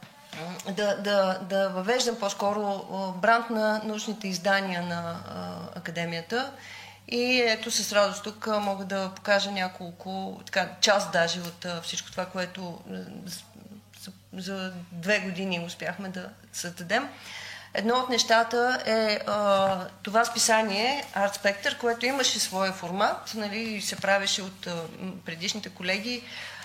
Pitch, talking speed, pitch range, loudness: 195 Hz, 125 wpm, 185-220 Hz, -27 LUFS